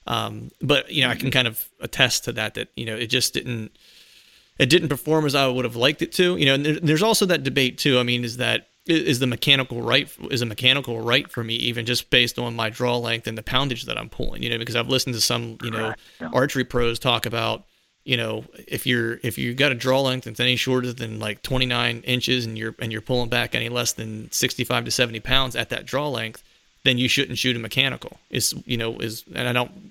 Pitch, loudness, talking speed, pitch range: 125 Hz, -22 LUFS, 245 wpm, 115-130 Hz